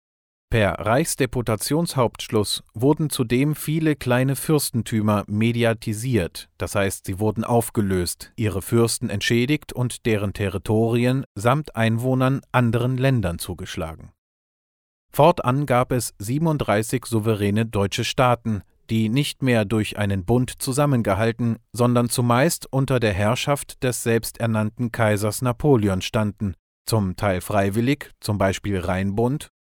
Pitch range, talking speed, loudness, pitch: 100-125 Hz, 110 wpm, -22 LUFS, 115 Hz